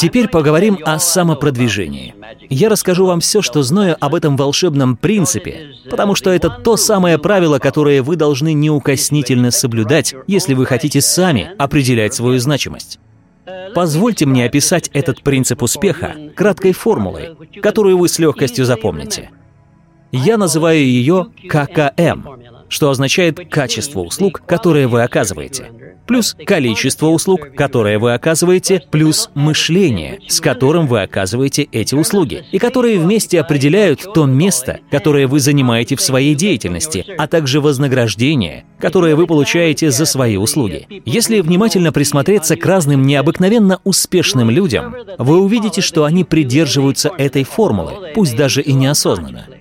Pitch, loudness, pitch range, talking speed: 150 Hz, -13 LUFS, 135-180 Hz, 135 wpm